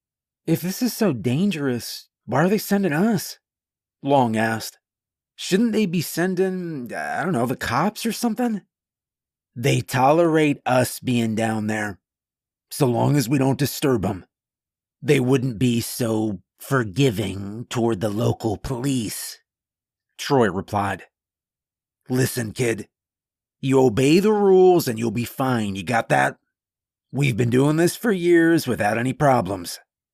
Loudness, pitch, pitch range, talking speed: -21 LUFS, 130 Hz, 115-170 Hz, 135 wpm